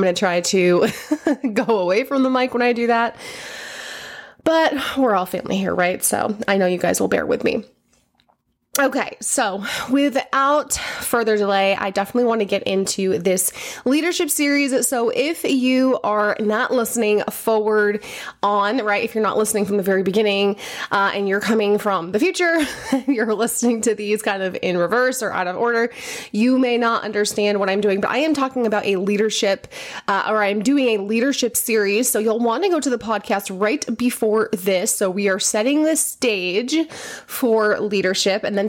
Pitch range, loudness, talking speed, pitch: 200-255 Hz, -19 LUFS, 185 wpm, 220 Hz